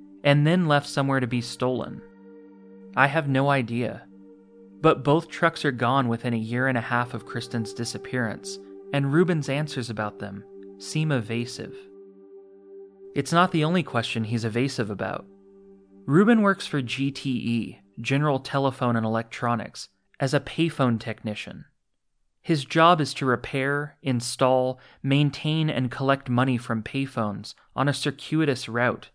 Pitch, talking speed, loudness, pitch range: 125 Hz, 140 wpm, -25 LUFS, 110-140 Hz